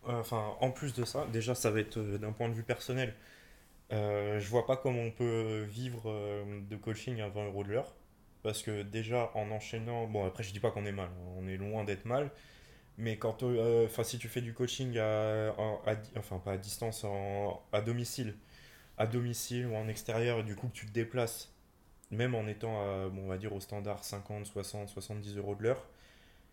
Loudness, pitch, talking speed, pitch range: -37 LUFS, 110 Hz, 215 wpm, 100-115 Hz